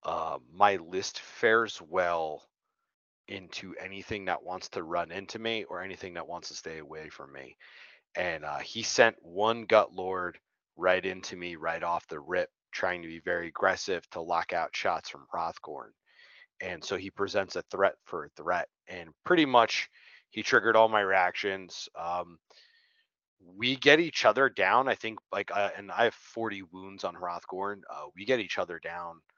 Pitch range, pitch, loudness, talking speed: 85-115 Hz, 95 Hz, -30 LUFS, 180 wpm